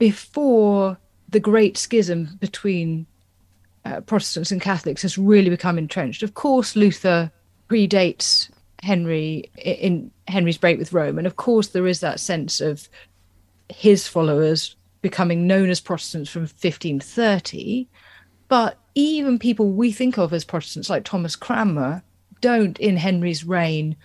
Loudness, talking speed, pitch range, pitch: -20 LUFS, 135 wpm, 160-205 Hz, 180 Hz